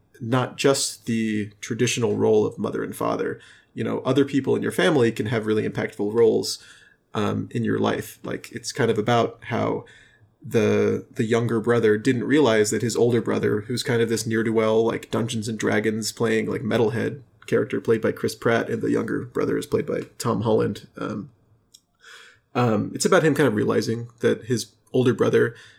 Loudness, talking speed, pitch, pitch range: -23 LUFS, 190 wpm, 115 Hz, 110-125 Hz